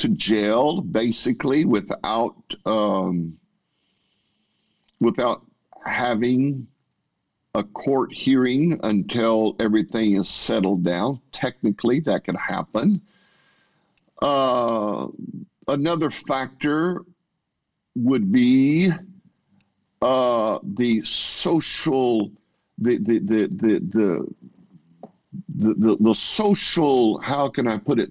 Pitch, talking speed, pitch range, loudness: 130 Hz, 85 wpm, 110-170 Hz, -21 LUFS